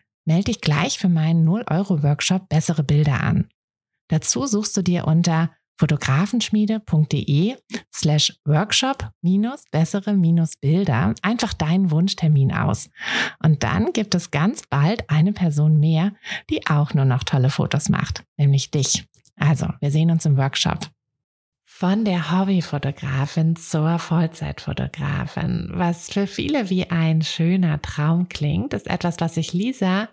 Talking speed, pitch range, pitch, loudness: 135 wpm, 150-185 Hz, 165 Hz, -20 LUFS